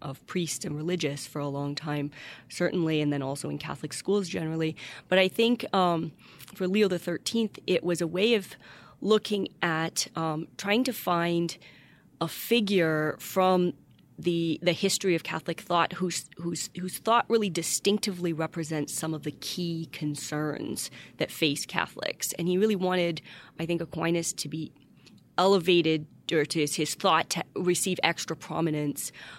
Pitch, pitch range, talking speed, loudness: 170 Hz, 155-185 Hz, 155 wpm, -28 LUFS